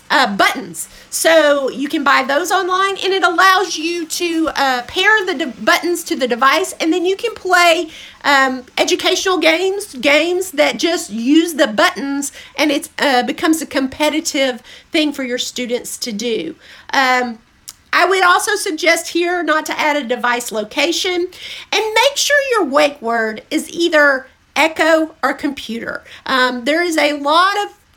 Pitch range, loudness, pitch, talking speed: 275-350 Hz, -15 LUFS, 310 Hz, 165 wpm